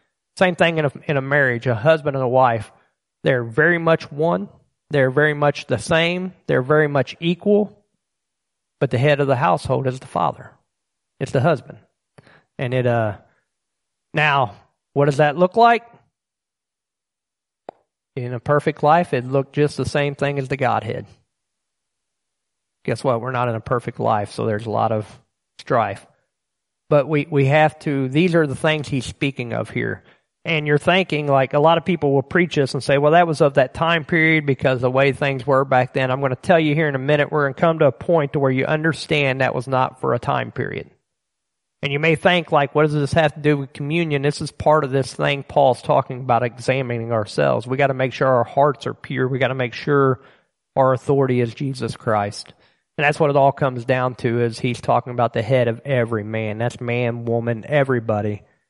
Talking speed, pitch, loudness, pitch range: 205 wpm, 140 Hz, -19 LUFS, 125-155 Hz